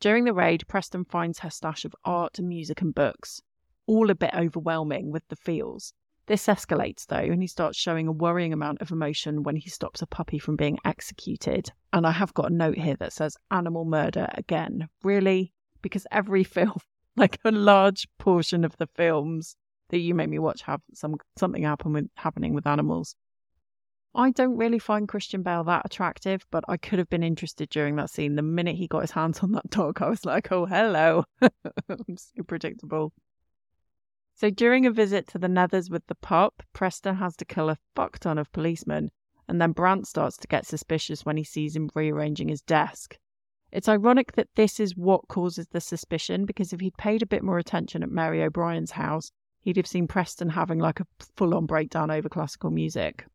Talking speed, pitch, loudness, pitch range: 200 wpm, 170 Hz, -26 LUFS, 155-195 Hz